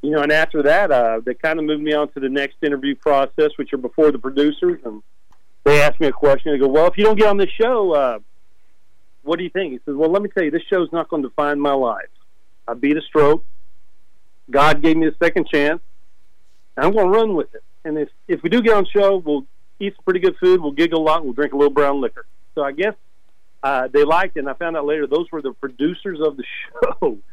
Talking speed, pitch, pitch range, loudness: 260 wpm, 150 Hz, 140-185 Hz, -18 LUFS